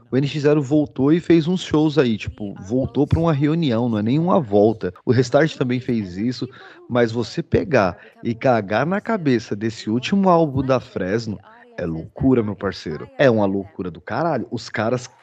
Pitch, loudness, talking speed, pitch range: 125 Hz, -20 LUFS, 175 wpm, 110-150 Hz